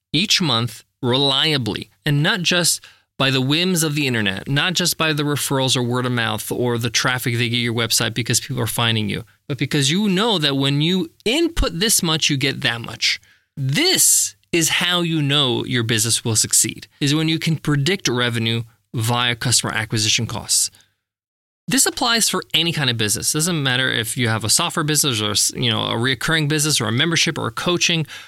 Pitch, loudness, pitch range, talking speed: 130 Hz, -18 LUFS, 115-160 Hz, 195 wpm